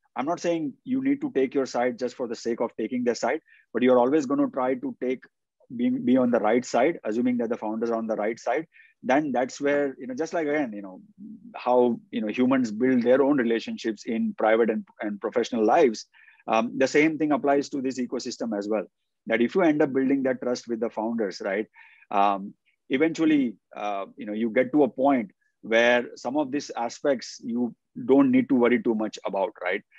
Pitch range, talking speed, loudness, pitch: 115-155 Hz, 220 wpm, -25 LUFS, 130 Hz